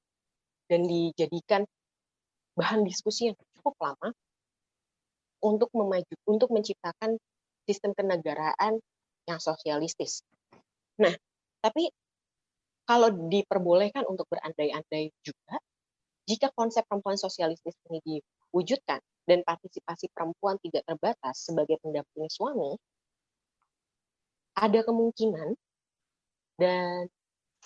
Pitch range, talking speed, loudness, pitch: 165-220 Hz, 85 wpm, -29 LUFS, 180 Hz